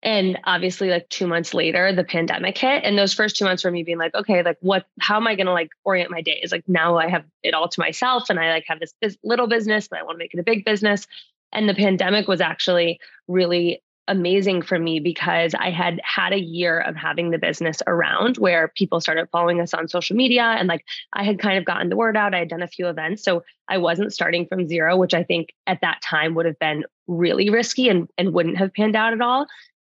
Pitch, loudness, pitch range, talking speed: 180 Hz, -20 LUFS, 170-205 Hz, 250 wpm